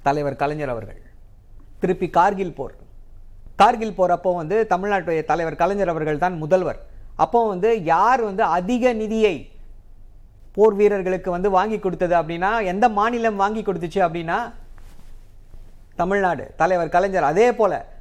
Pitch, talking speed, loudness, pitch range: 180 Hz, 125 wpm, -20 LUFS, 135-200 Hz